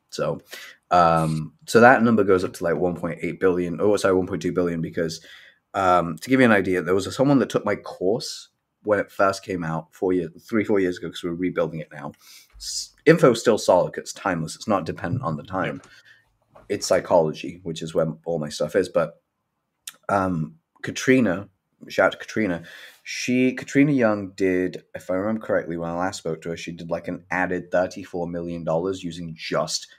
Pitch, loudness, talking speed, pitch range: 90 Hz, -23 LUFS, 205 wpm, 85-95 Hz